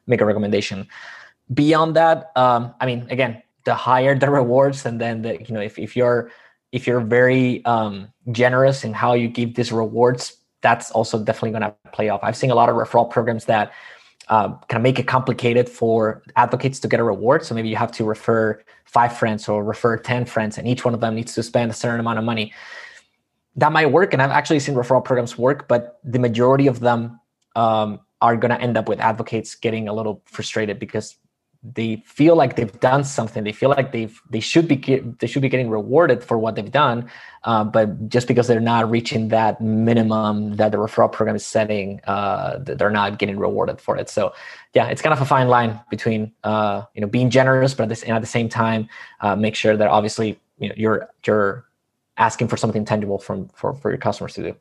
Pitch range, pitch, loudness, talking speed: 110-125 Hz, 115 Hz, -19 LUFS, 220 wpm